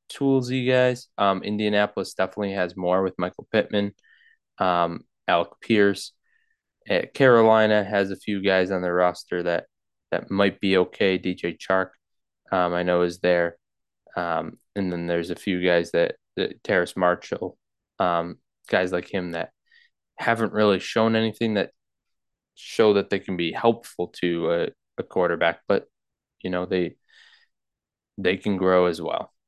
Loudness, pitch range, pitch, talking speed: -24 LUFS, 90-105 Hz, 95 Hz, 155 wpm